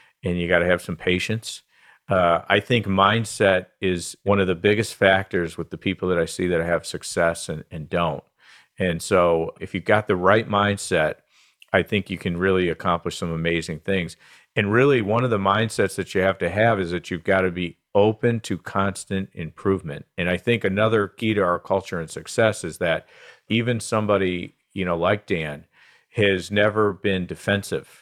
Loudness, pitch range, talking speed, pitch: -22 LUFS, 90-105 Hz, 190 wpm, 95 Hz